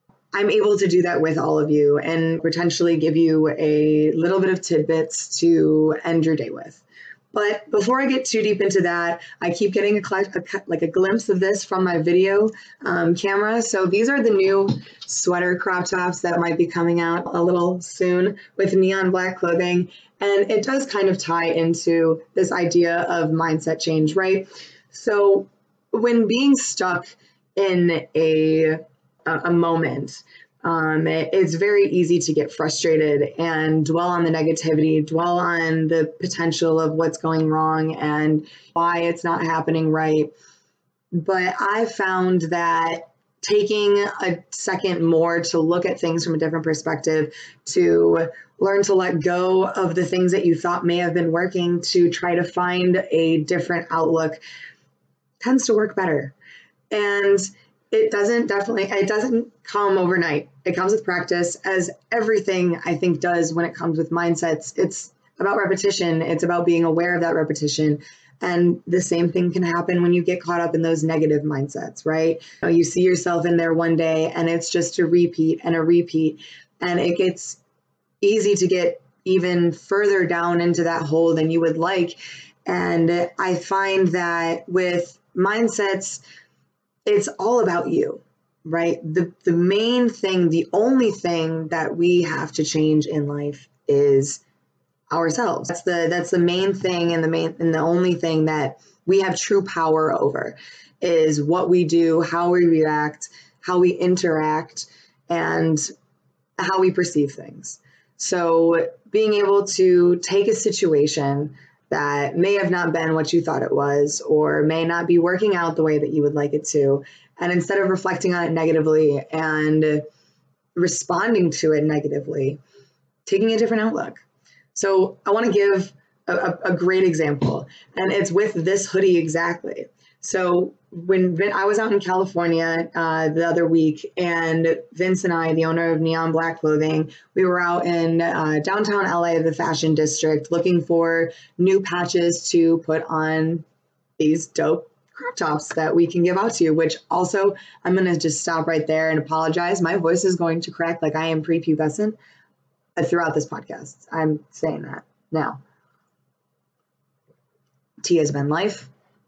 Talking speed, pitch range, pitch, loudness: 165 wpm, 160-185 Hz, 170 Hz, -20 LUFS